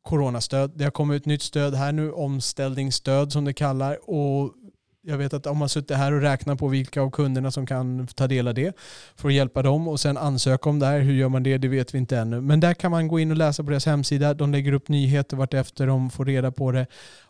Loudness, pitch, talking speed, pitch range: -23 LUFS, 140 Hz, 255 wpm, 135-145 Hz